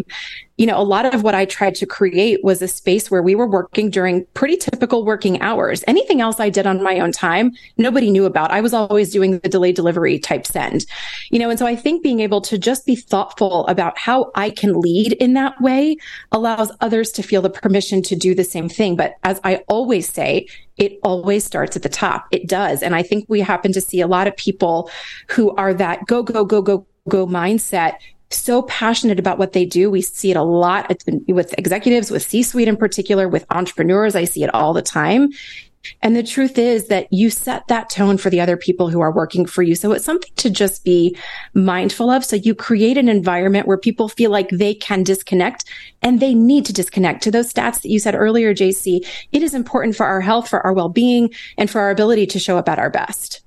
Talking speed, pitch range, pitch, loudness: 230 wpm, 185-230 Hz, 205 Hz, -16 LUFS